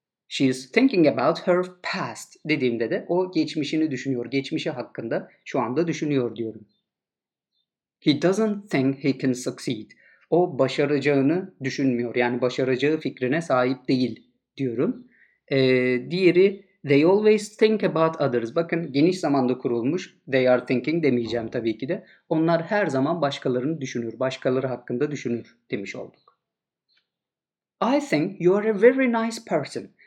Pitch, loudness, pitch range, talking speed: 140 Hz, -23 LUFS, 130-175 Hz, 135 wpm